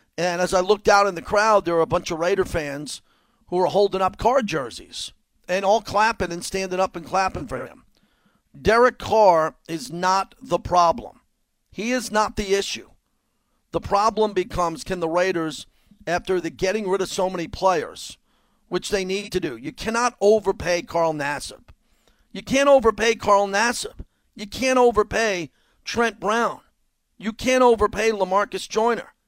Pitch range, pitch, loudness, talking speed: 175-220 Hz, 195 Hz, -21 LUFS, 165 wpm